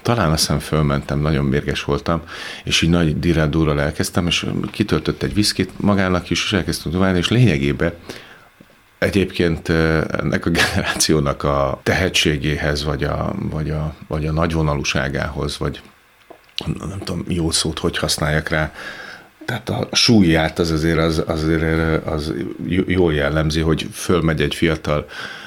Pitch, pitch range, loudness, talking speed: 80 Hz, 75-85 Hz, -19 LUFS, 135 wpm